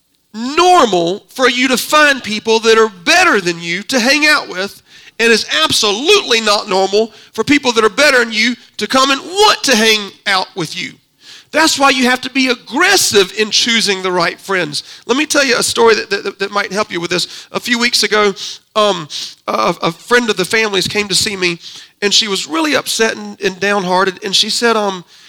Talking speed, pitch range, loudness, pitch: 210 wpm, 195-260 Hz, -12 LUFS, 220 Hz